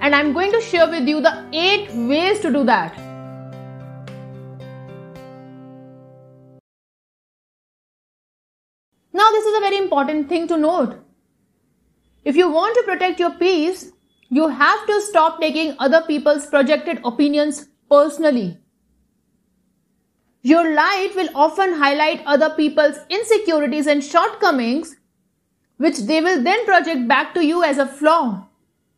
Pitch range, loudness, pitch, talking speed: 225-335 Hz, -17 LUFS, 295 Hz, 125 wpm